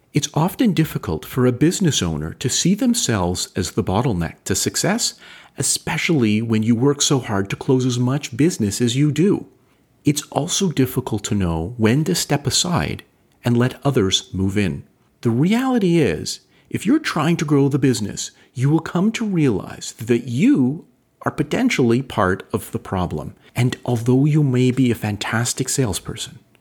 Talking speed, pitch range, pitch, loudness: 165 wpm, 115-155 Hz, 130 Hz, -19 LUFS